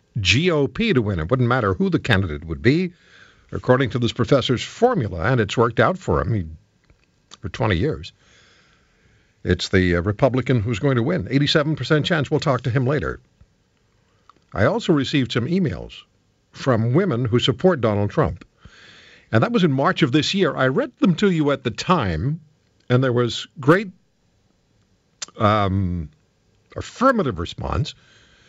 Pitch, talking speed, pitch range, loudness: 130 Hz, 155 wpm, 110-155 Hz, -20 LUFS